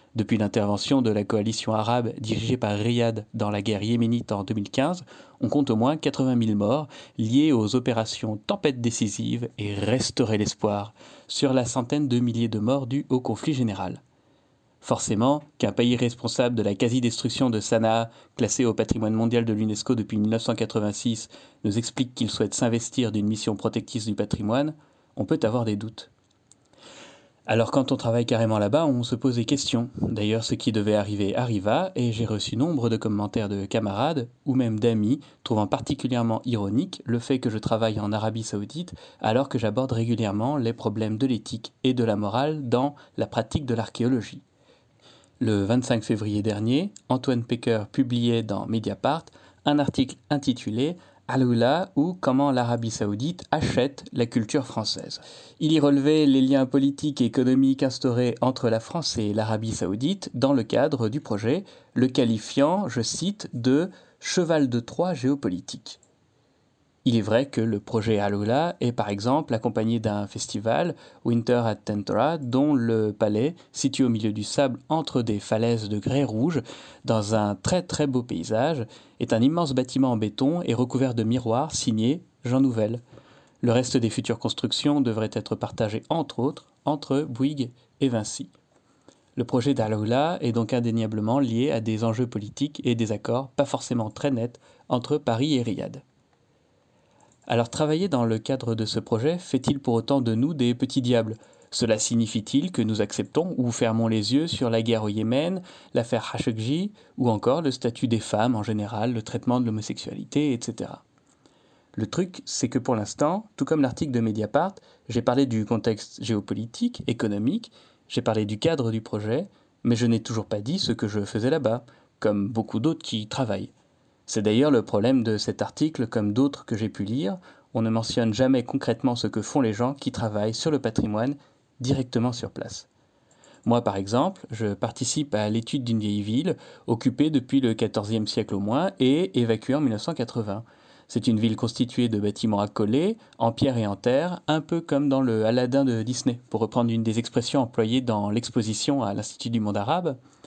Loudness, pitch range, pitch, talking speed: -25 LUFS, 110-135 Hz, 120 Hz, 175 wpm